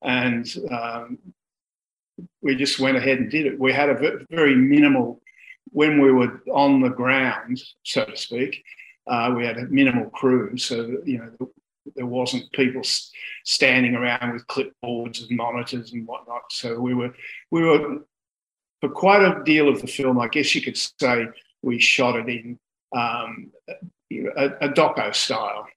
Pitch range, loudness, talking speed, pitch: 120-145 Hz, -21 LUFS, 160 wpm, 130 Hz